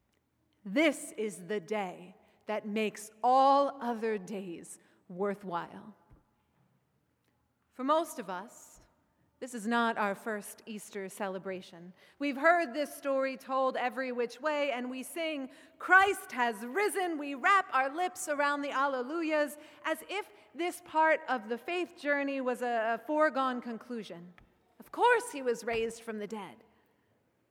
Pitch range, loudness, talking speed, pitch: 215-300 Hz, -32 LUFS, 135 wpm, 255 Hz